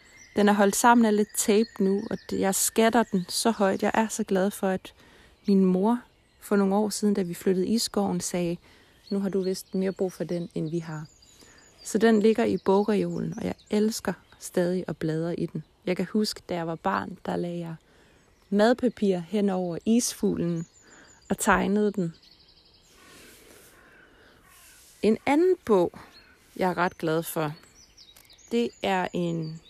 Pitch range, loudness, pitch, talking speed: 175-215 Hz, -26 LUFS, 195 Hz, 170 wpm